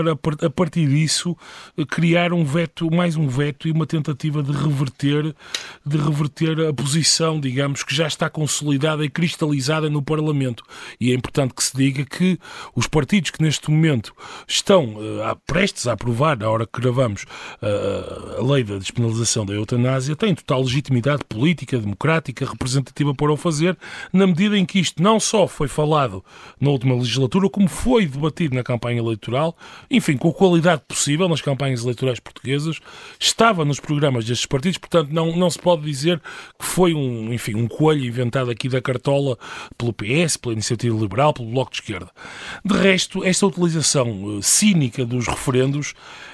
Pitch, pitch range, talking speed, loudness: 150 Hz, 130-165 Hz, 165 wpm, -20 LUFS